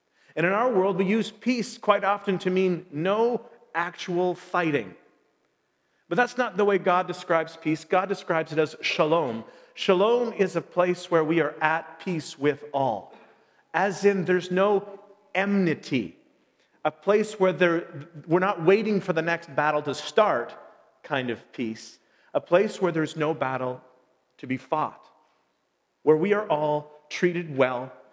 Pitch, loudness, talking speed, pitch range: 180 Hz, -25 LUFS, 160 wpm, 155-200 Hz